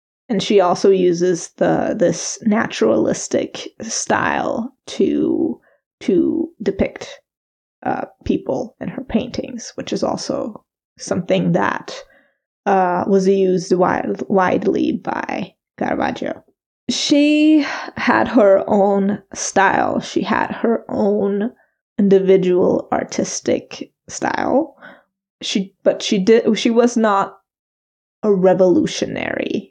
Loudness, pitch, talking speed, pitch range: -18 LUFS, 210 Hz, 100 wpm, 195-265 Hz